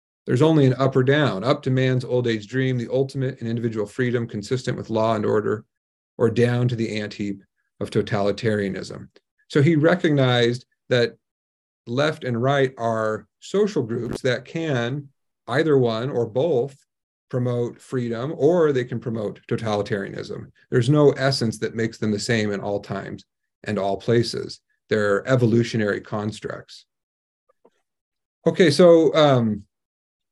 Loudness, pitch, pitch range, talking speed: -22 LUFS, 120 Hz, 105-130 Hz, 145 wpm